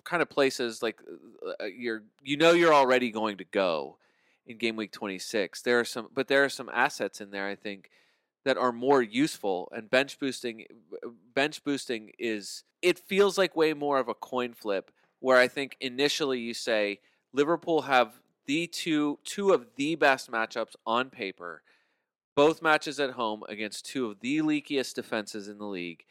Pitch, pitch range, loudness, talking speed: 130 Hz, 110-155 Hz, -28 LUFS, 175 wpm